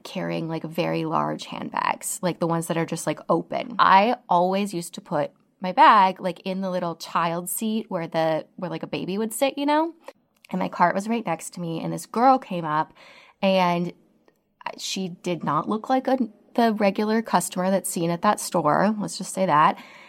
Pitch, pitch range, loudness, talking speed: 185 Hz, 165-210 Hz, -23 LUFS, 205 wpm